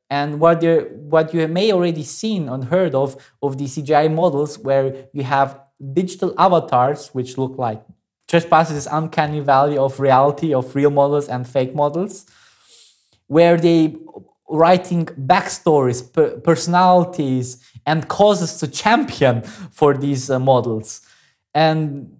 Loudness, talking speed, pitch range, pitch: -18 LUFS, 130 wpm, 135-165 Hz, 145 Hz